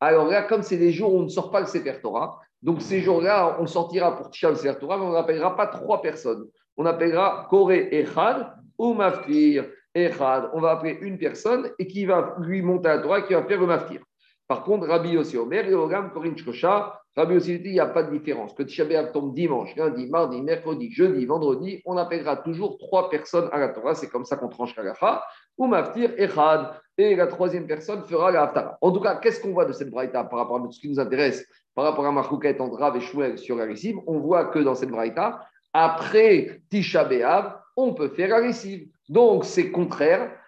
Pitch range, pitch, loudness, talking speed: 150-200 Hz, 170 Hz, -23 LUFS, 220 wpm